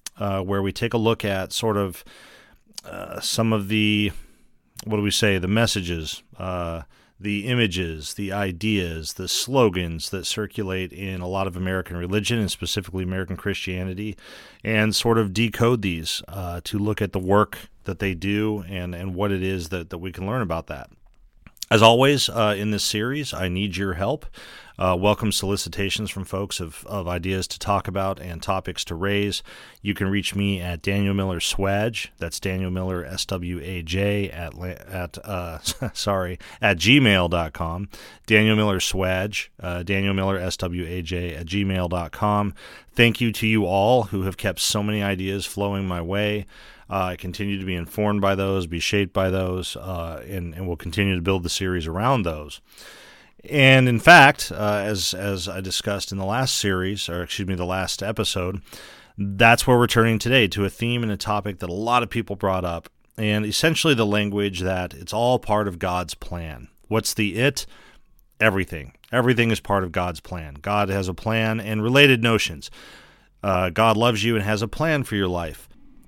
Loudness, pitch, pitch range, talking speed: -22 LUFS, 100 Hz, 90-105 Hz, 180 wpm